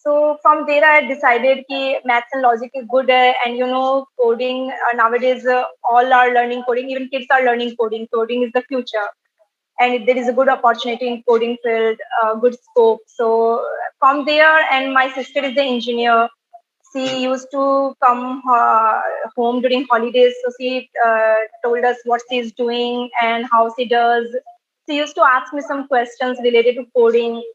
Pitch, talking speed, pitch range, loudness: 250 Hz, 185 wpm, 235-265 Hz, -16 LUFS